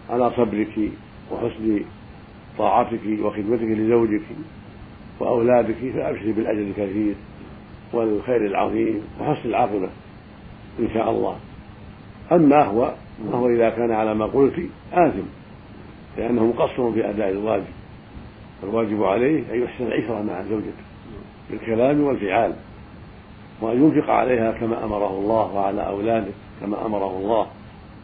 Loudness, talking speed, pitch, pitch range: -22 LUFS, 110 wpm, 110 Hz, 105-115 Hz